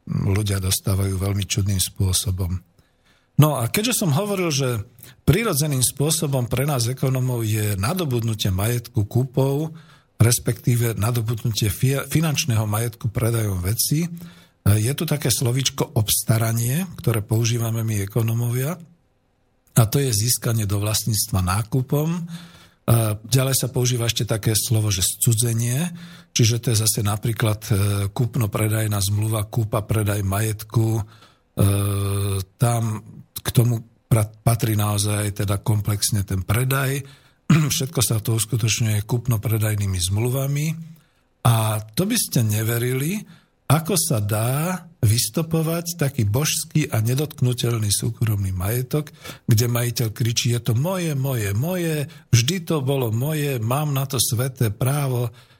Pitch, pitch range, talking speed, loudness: 120 Hz, 110-140 Hz, 115 wpm, -21 LUFS